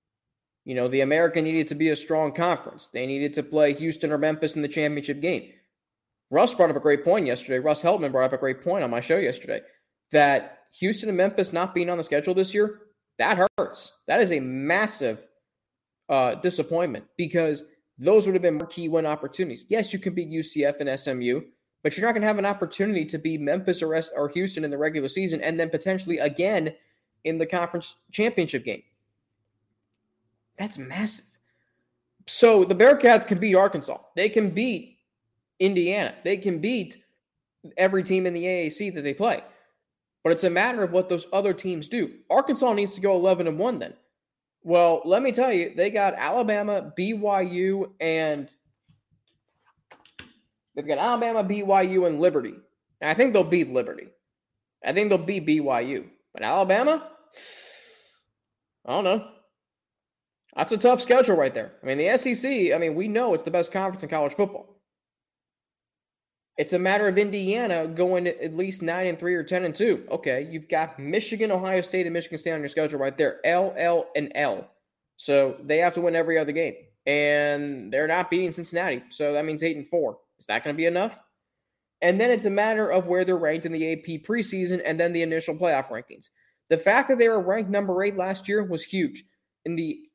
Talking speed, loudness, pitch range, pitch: 190 wpm, -24 LUFS, 150-195 Hz, 175 Hz